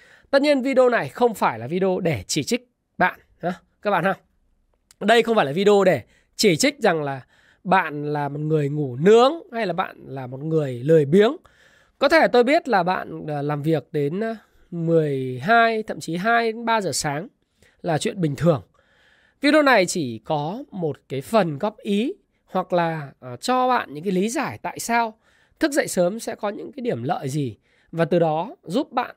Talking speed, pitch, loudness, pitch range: 195 wpm, 190 Hz, -21 LUFS, 155-230 Hz